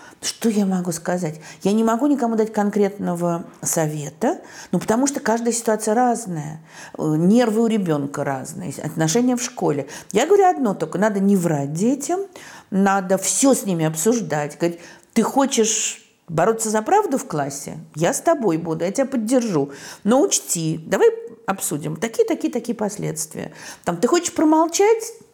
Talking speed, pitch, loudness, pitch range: 145 wpm, 215 Hz, -20 LUFS, 170-250 Hz